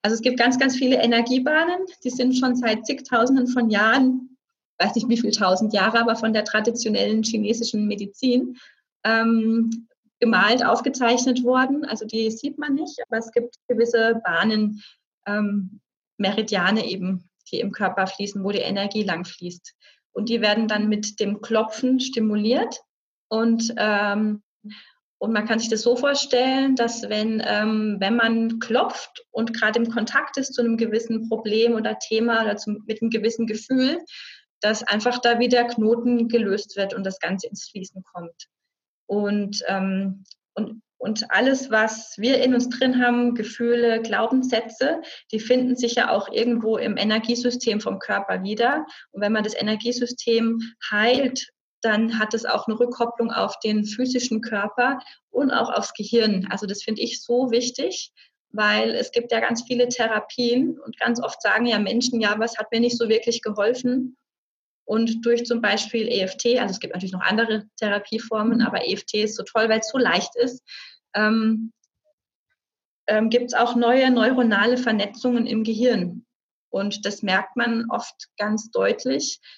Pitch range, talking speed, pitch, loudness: 215-245 Hz, 160 wpm, 230 Hz, -22 LUFS